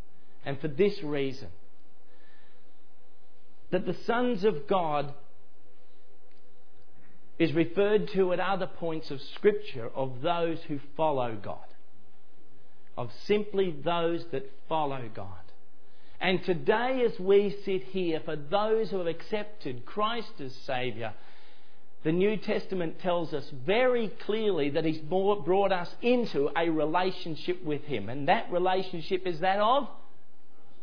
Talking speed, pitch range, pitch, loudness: 125 wpm, 135-195 Hz, 165 Hz, -30 LUFS